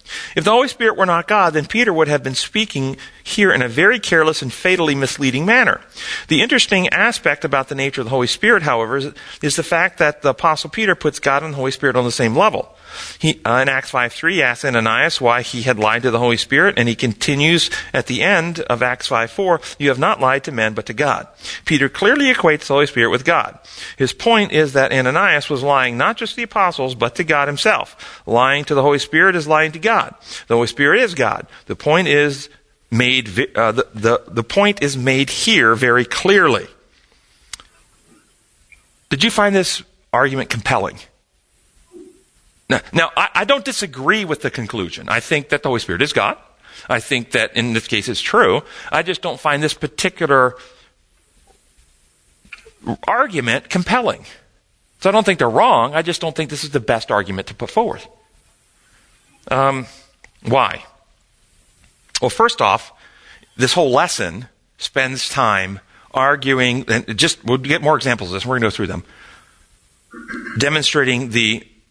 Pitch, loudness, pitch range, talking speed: 140 Hz, -16 LUFS, 120-165 Hz, 185 wpm